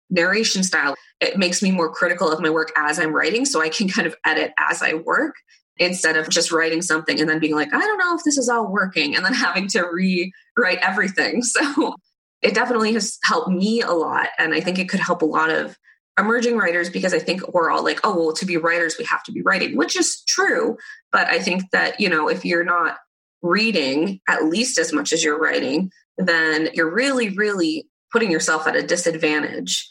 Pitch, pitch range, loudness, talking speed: 175 Hz, 160-225 Hz, -19 LUFS, 220 wpm